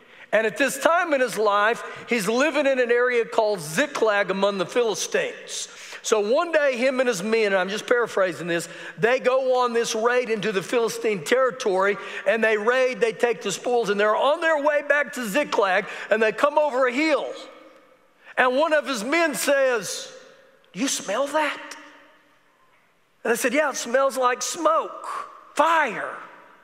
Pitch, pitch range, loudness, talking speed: 255 Hz, 225-300 Hz, -22 LUFS, 175 wpm